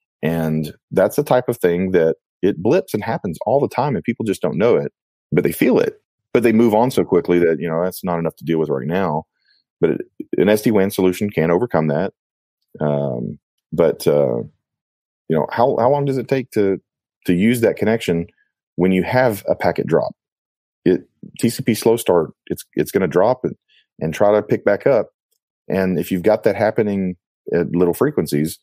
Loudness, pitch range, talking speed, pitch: -18 LUFS, 85-125 Hz, 205 wpm, 100 Hz